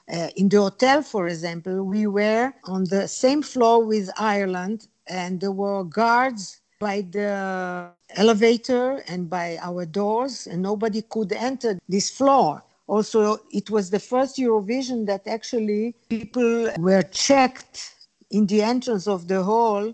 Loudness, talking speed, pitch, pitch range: -22 LUFS, 145 wpm, 210 Hz, 190-230 Hz